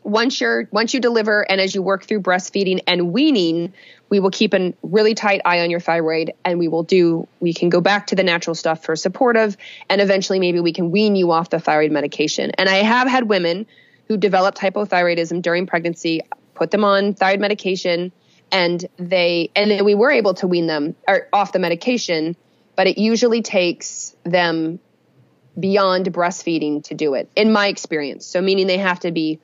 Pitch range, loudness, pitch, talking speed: 170-205 Hz, -18 LUFS, 185 Hz, 195 wpm